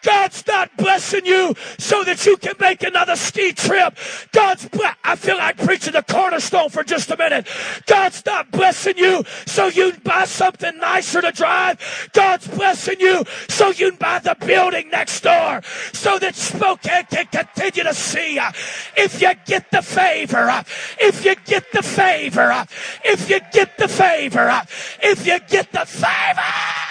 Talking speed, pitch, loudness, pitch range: 175 wpm, 370 Hz, -17 LUFS, 345-390 Hz